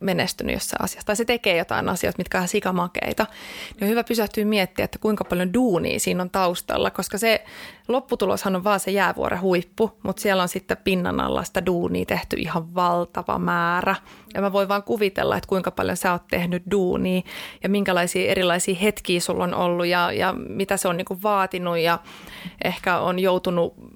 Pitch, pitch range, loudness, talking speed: 185 Hz, 175-200 Hz, -23 LUFS, 185 wpm